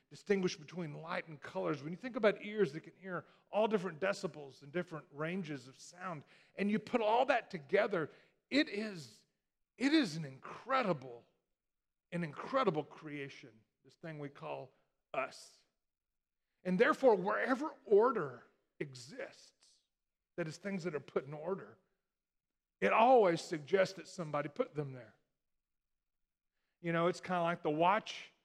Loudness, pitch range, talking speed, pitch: -36 LUFS, 150-200 Hz, 150 wpm, 175 Hz